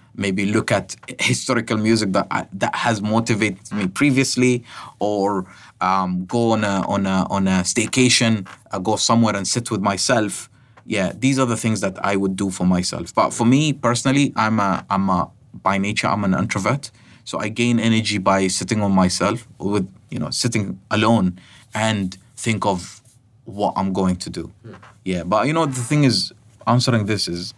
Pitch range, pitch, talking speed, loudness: 95-120 Hz, 110 Hz, 180 wpm, -20 LUFS